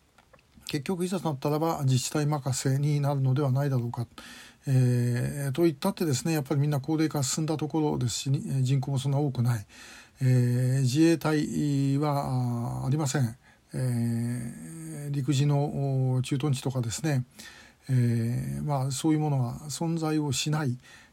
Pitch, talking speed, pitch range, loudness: 140 Hz, 305 characters per minute, 125-150 Hz, -28 LUFS